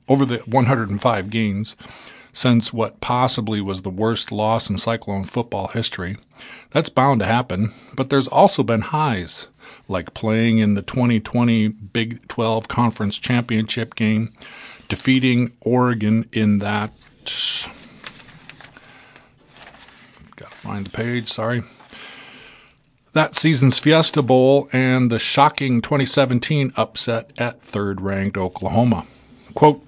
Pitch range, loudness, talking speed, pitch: 110-130 Hz, -19 LUFS, 115 wpm, 115 Hz